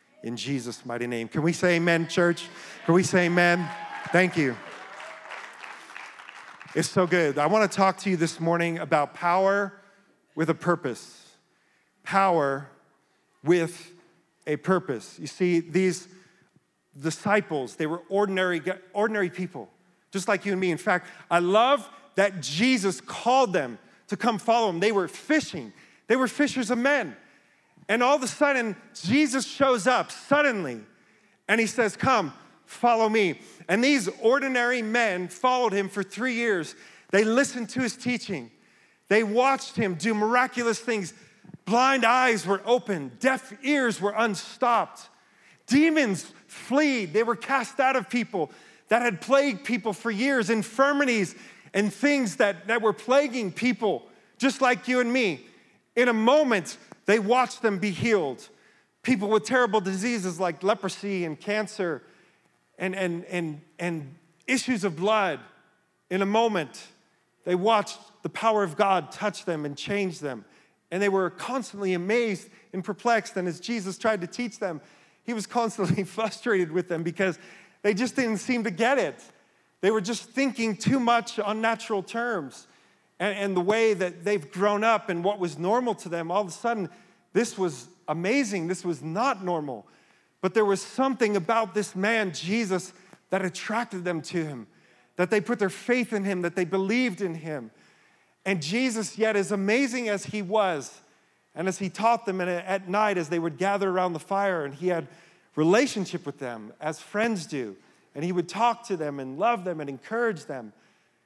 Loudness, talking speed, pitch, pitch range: -26 LUFS, 165 wpm, 200 Hz, 180-235 Hz